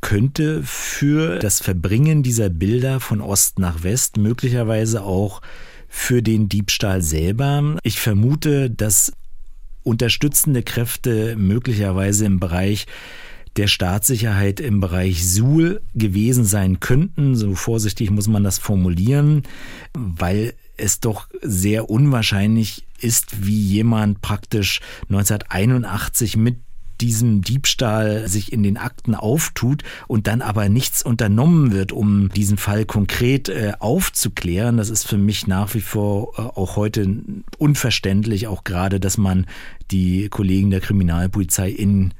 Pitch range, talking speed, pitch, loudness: 100-120 Hz, 120 wpm, 105 Hz, -18 LUFS